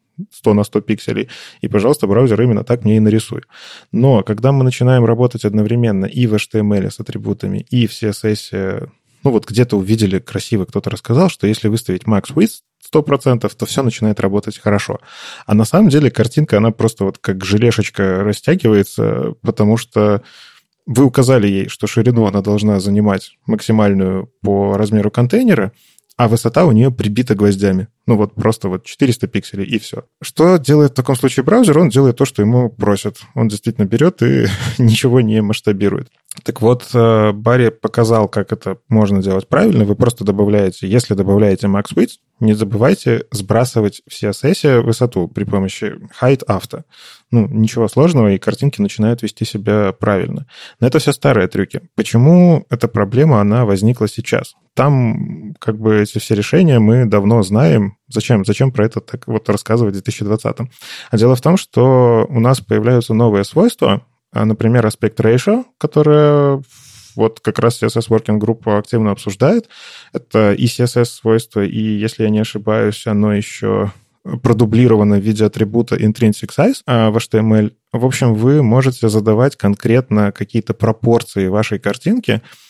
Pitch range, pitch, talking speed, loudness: 105-125 Hz, 110 Hz, 160 wpm, -14 LUFS